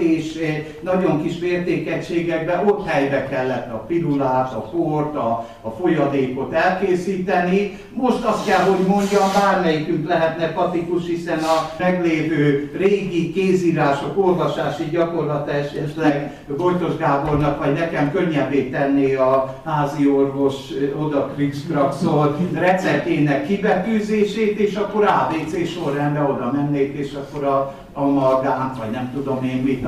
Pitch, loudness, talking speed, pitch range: 155 Hz, -20 LUFS, 120 wpm, 140-175 Hz